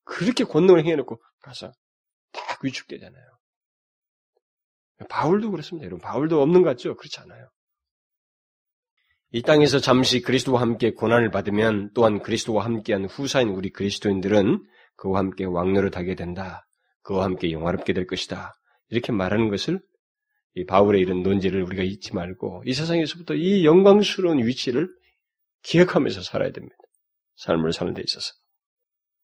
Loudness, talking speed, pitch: -22 LUFS, 340 characters per minute, 125 Hz